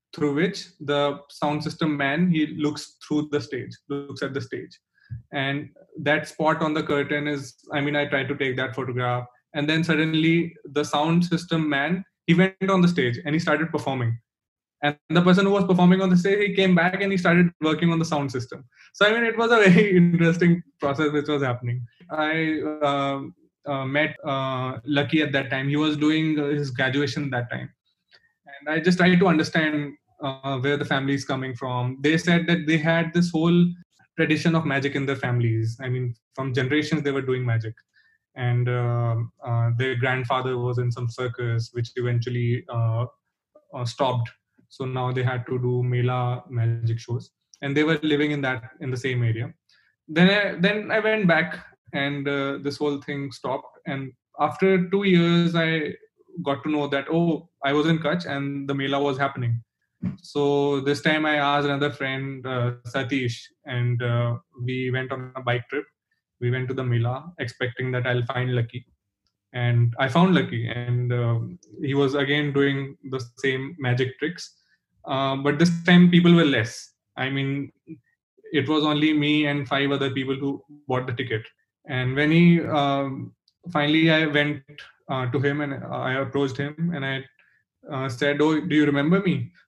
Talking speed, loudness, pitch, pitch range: 185 wpm, -23 LUFS, 140 Hz, 130-160 Hz